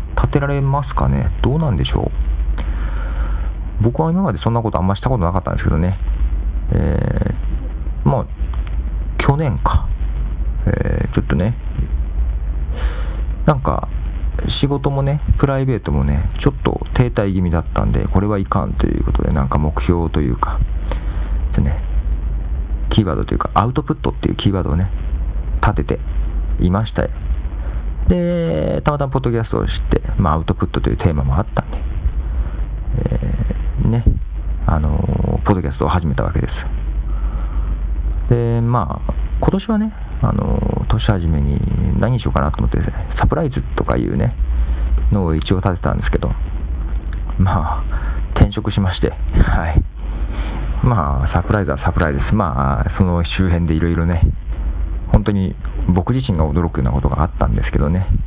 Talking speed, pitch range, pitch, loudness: 315 characters per minute, 65-100 Hz, 80 Hz, -19 LUFS